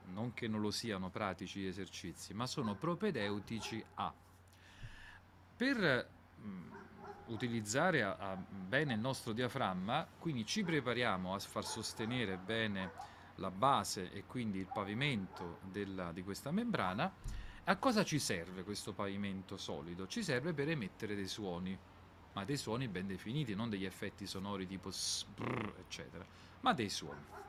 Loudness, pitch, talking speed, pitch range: -40 LUFS, 100 Hz, 145 wpm, 95-120 Hz